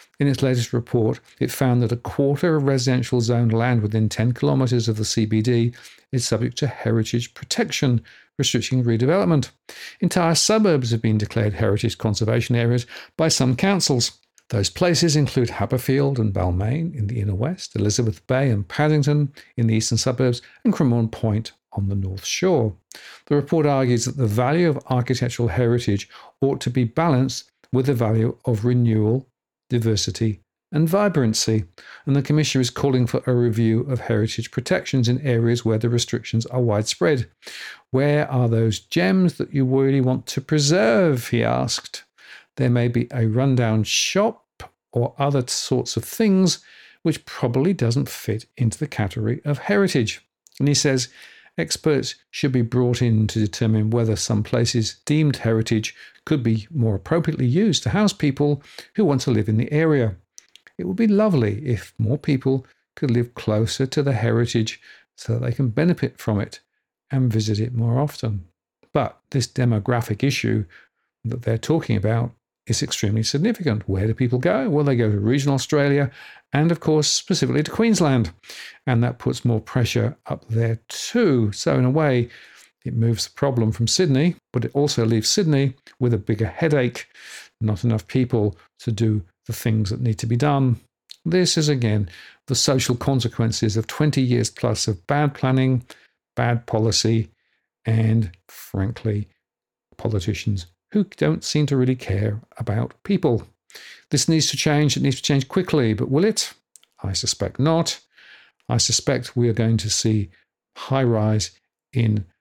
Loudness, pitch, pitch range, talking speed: -21 LUFS, 120 Hz, 110-140 Hz, 165 wpm